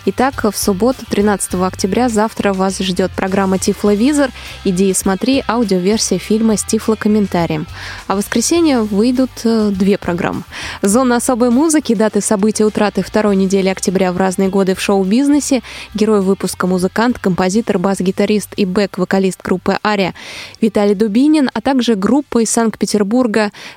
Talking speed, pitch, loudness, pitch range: 135 wpm, 210 Hz, -14 LUFS, 195-230 Hz